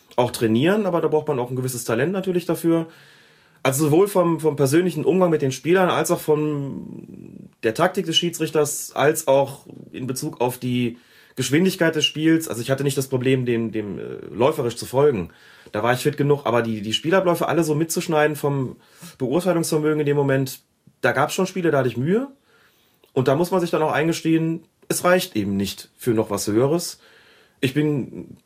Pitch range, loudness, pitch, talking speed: 125-170 Hz, -21 LUFS, 150 Hz, 195 wpm